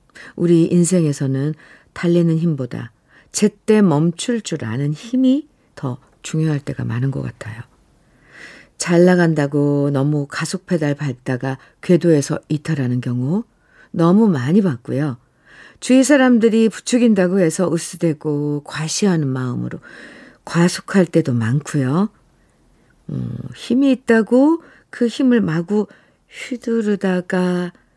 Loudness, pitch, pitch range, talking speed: -18 LUFS, 170 Hz, 145-210 Hz, 245 characters per minute